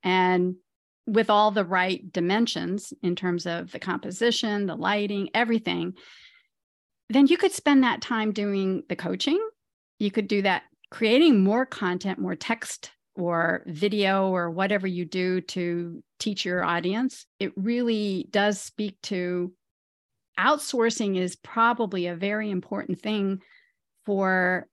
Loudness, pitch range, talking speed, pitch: -25 LUFS, 180-225 Hz, 135 wpm, 200 Hz